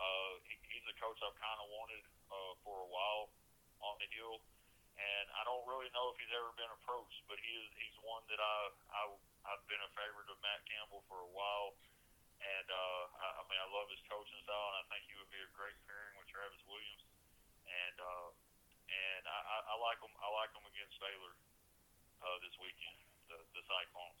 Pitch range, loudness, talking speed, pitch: 95-105 Hz, -46 LUFS, 205 wpm, 100 Hz